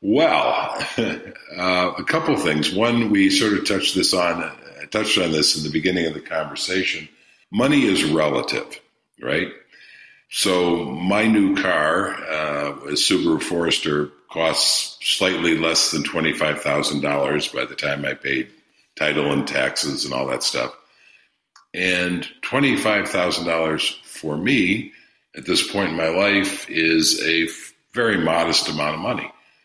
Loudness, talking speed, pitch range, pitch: -20 LUFS, 140 wpm, 80-100 Hz, 85 Hz